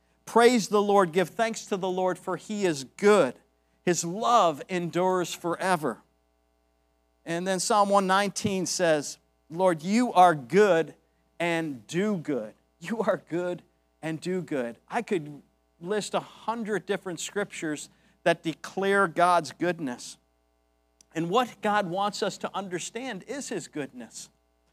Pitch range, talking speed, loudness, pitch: 145-200 Hz, 135 wpm, -27 LUFS, 180 Hz